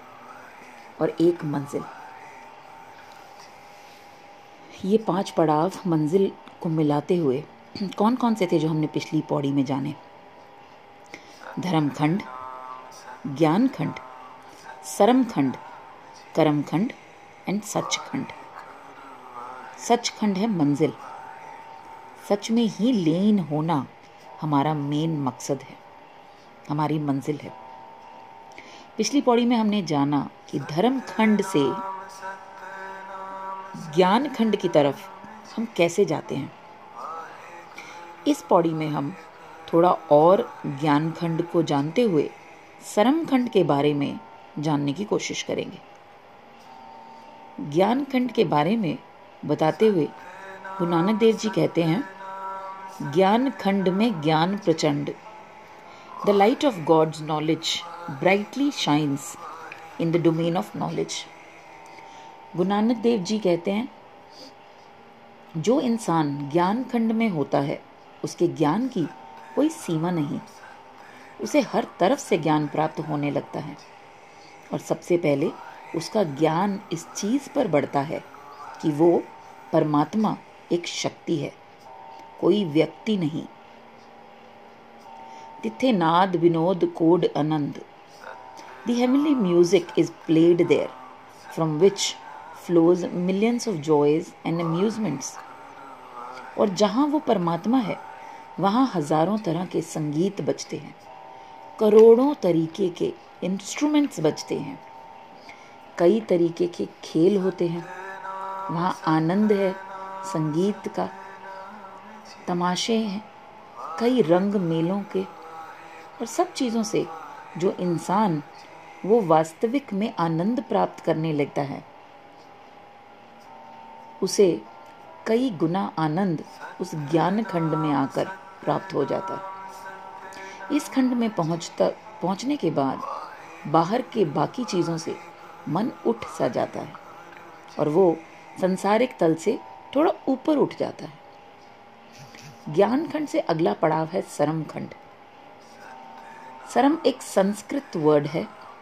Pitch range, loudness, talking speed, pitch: 160-215 Hz, -24 LUFS, 115 wpm, 180 Hz